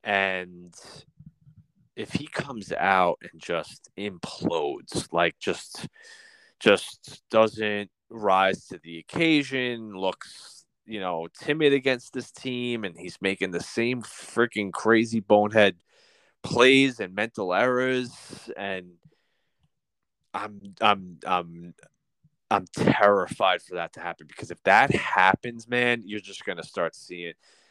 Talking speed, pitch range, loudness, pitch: 120 wpm, 95-135 Hz, -25 LUFS, 115 Hz